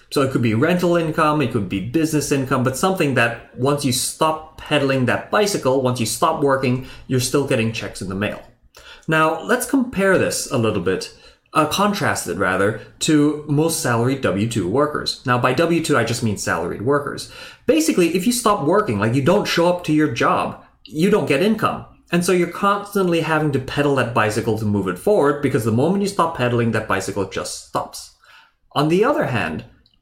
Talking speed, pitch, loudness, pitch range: 200 wpm, 140 Hz, -19 LUFS, 115-165 Hz